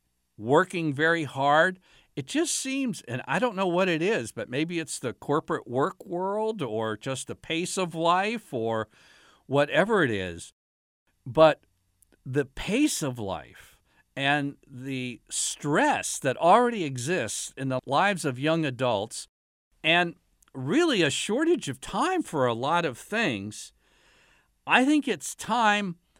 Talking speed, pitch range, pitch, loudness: 140 wpm, 120-185 Hz, 145 Hz, -26 LUFS